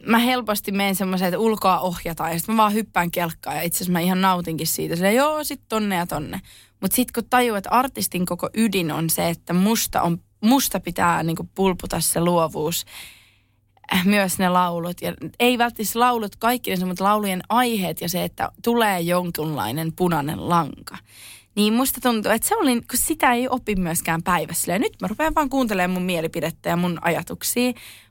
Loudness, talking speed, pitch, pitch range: -21 LUFS, 185 wpm, 185 Hz, 170-225 Hz